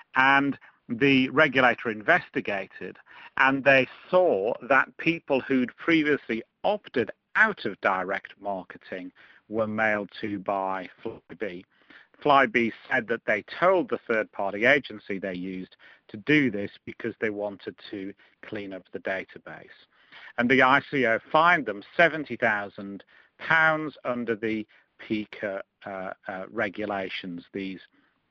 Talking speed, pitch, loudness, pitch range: 120 wpm, 115 Hz, -25 LUFS, 100-140 Hz